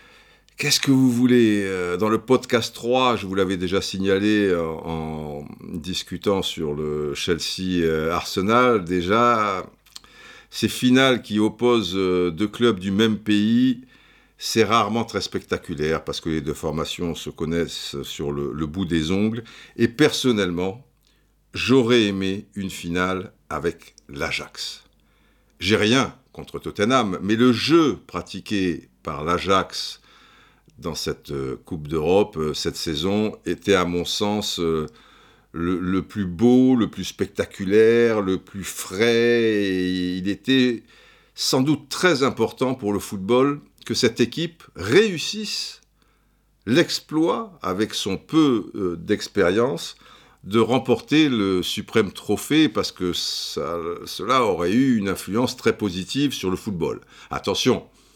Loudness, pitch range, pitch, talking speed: -22 LUFS, 90-120 Hz, 105 Hz, 125 wpm